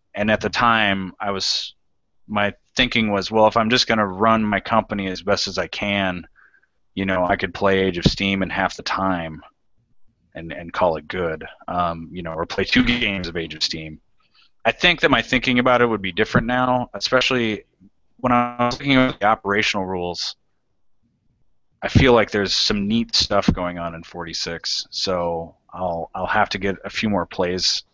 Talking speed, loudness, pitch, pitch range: 195 wpm, -20 LUFS, 100 Hz, 90-115 Hz